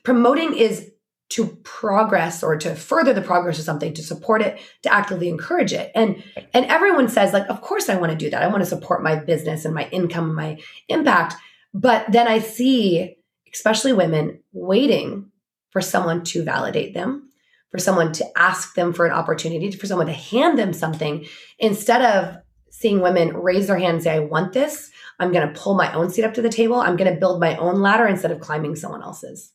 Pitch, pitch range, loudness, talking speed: 185 Hz, 165-225 Hz, -20 LUFS, 210 wpm